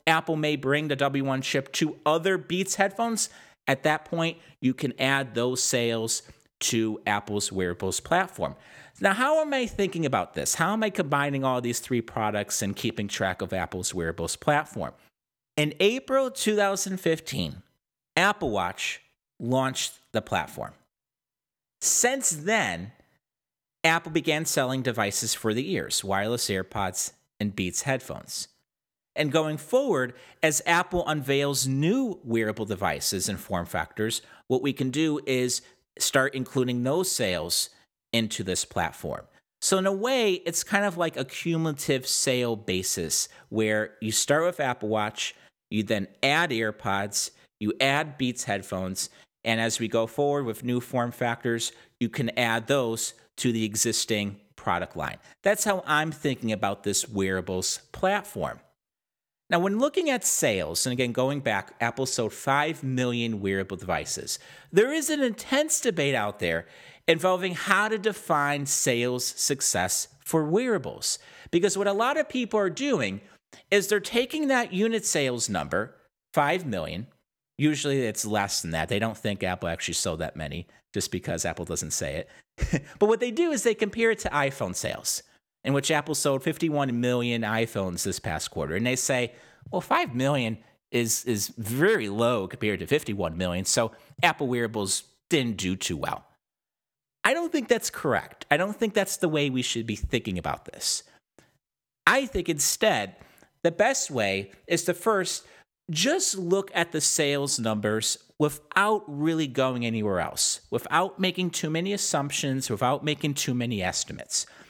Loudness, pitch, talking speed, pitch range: -26 LUFS, 135 Hz, 155 wpm, 110-170 Hz